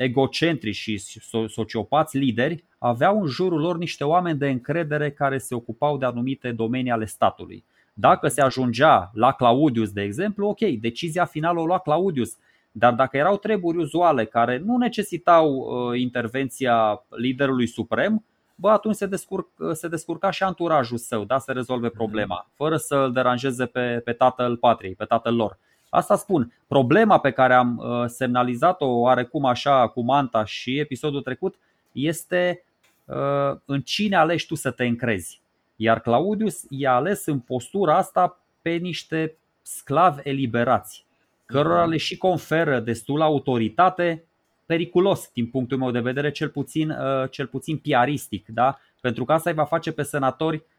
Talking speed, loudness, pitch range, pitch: 150 wpm, -22 LUFS, 120-165 Hz, 140 Hz